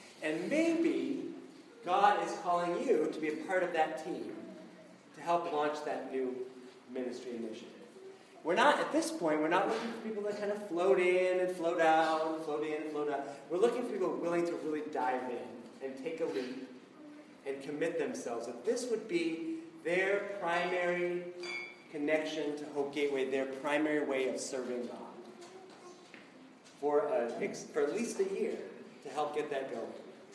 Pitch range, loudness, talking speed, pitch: 140-210 Hz, -34 LUFS, 170 wpm, 160 Hz